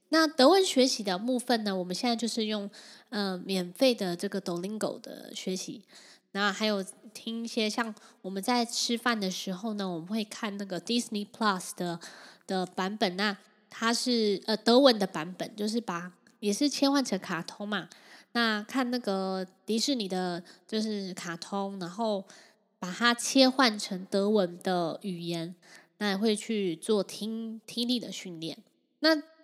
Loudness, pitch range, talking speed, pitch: -29 LUFS, 190-235 Hz, 255 characters per minute, 210 Hz